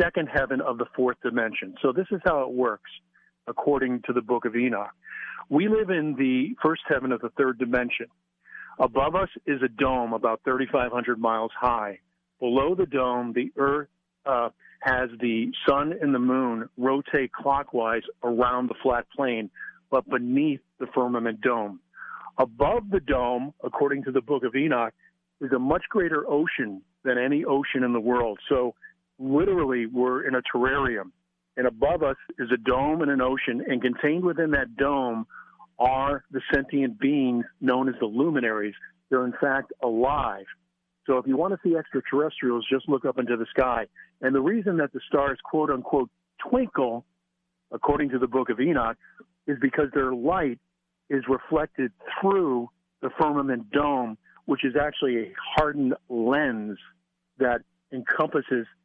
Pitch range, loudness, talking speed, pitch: 125-155 Hz, -26 LUFS, 160 wpm, 135 Hz